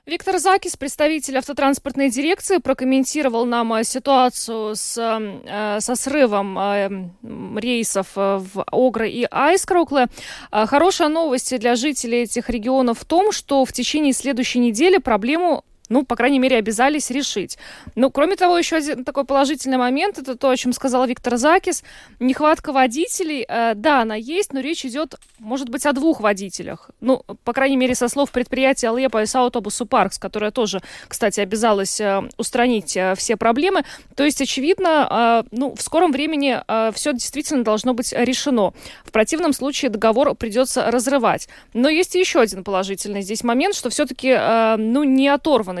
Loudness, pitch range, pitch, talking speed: -19 LUFS, 225-285 Hz, 255 Hz, 155 wpm